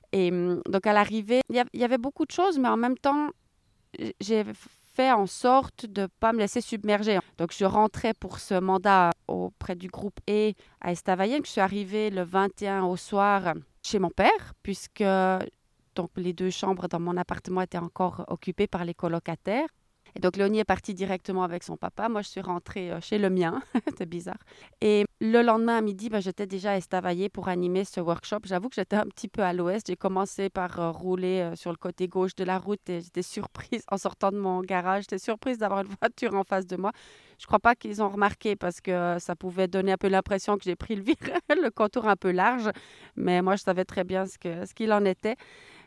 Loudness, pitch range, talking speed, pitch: -27 LUFS, 185-215 Hz, 215 wpm, 195 Hz